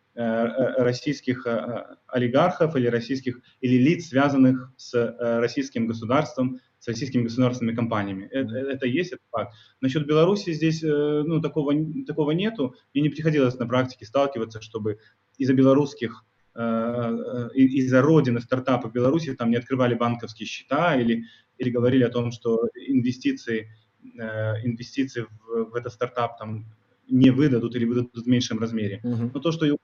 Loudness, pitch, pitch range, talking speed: -24 LUFS, 125 Hz, 115-135 Hz, 135 wpm